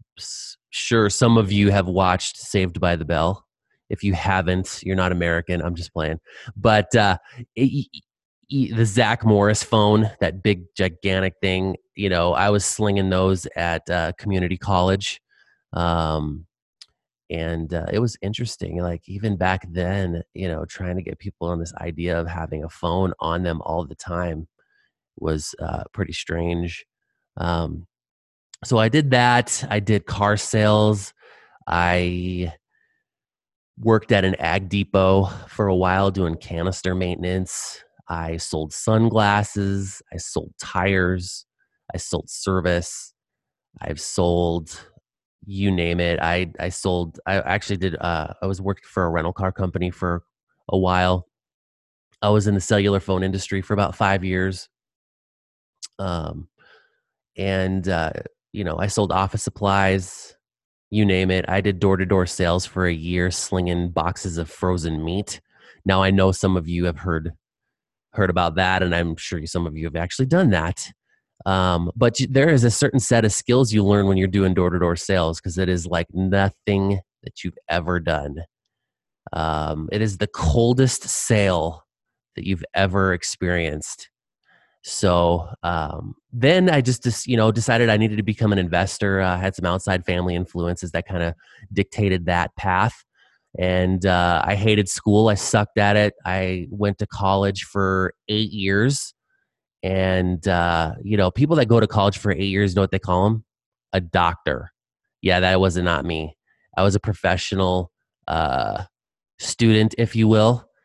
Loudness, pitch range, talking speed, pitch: -21 LUFS, 85-105 Hz, 160 wpm, 95 Hz